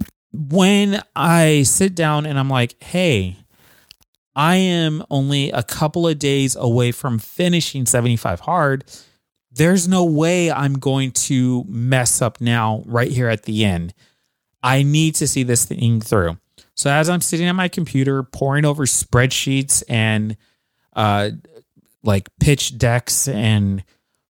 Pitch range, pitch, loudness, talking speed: 115-155 Hz, 135 Hz, -17 LUFS, 140 wpm